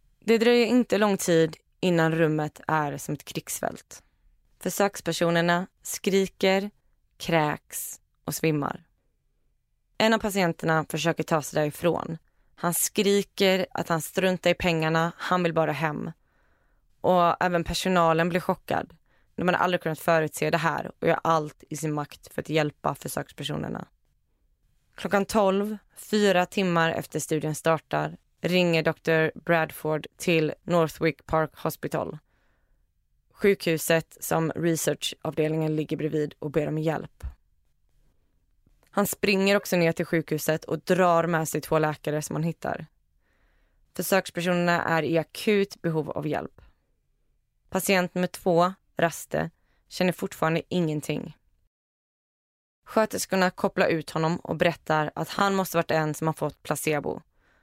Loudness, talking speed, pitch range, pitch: -26 LUFS, 130 wpm, 155-180 Hz, 165 Hz